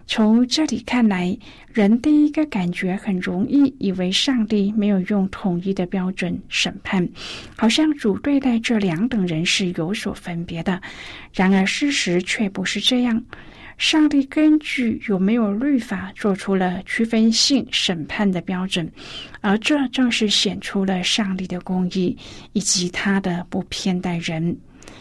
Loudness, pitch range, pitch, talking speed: -20 LUFS, 185-235 Hz, 205 Hz, 220 characters per minute